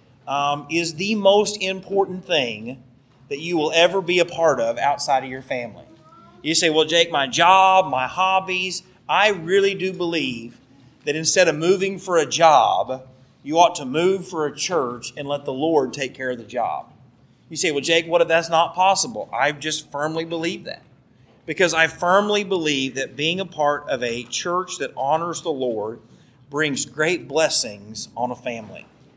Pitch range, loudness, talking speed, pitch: 135-180 Hz, -20 LUFS, 180 wpm, 160 Hz